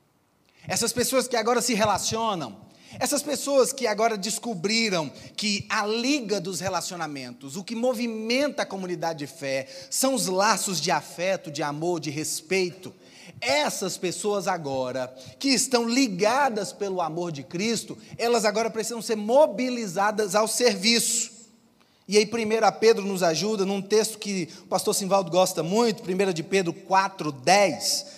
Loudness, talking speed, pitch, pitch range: -25 LUFS, 145 wpm, 205 Hz, 180-230 Hz